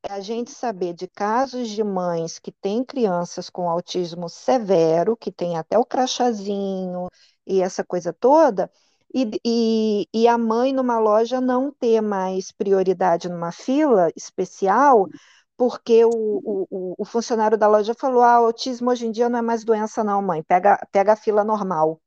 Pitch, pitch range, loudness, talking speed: 215 Hz, 185-235 Hz, -20 LUFS, 165 wpm